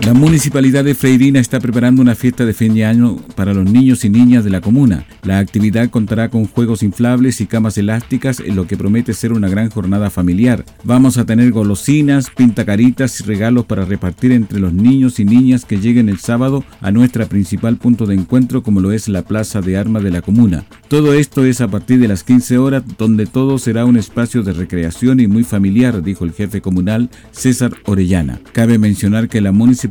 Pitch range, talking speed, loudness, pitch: 100-125 Hz, 205 wpm, -13 LUFS, 115 Hz